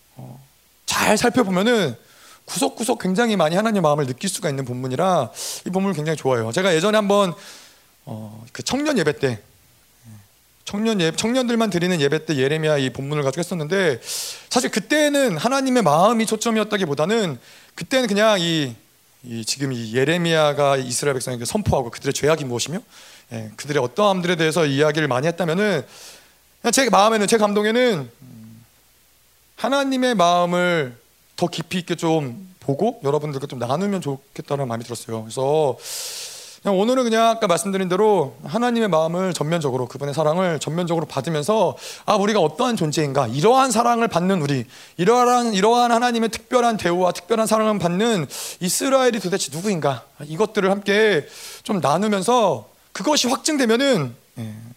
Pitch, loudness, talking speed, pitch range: 180 Hz, -20 LUFS, 365 characters per minute, 140-225 Hz